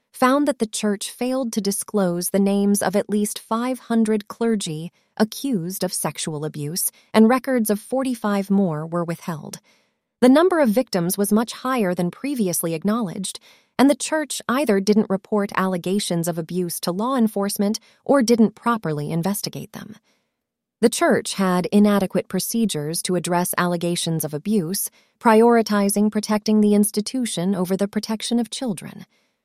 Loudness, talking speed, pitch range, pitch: -21 LUFS, 145 wpm, 185-230 Hz, 210 Hz